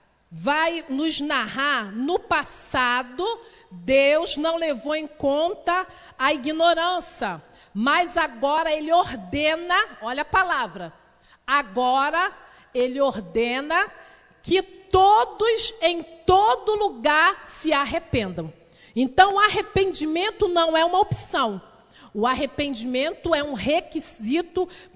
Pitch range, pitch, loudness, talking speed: 265-360 Hz, 315 Hz, -22 LUFS, 100 wpm